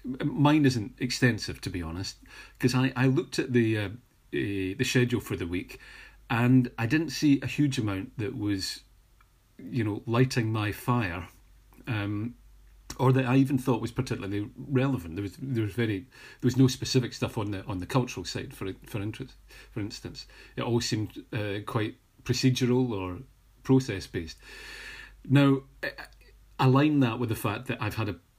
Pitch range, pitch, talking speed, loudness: 105-130 Hz, 120 Hz, 175 wpm, -28 LUFS